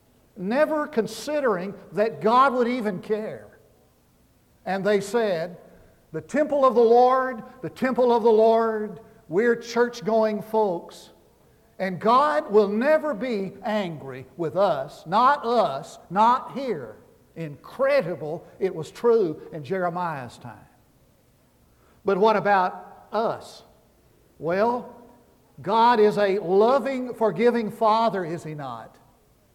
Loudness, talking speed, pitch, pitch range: -23 LUFS, 115 wpm, 220 Hz, 190-240 Hz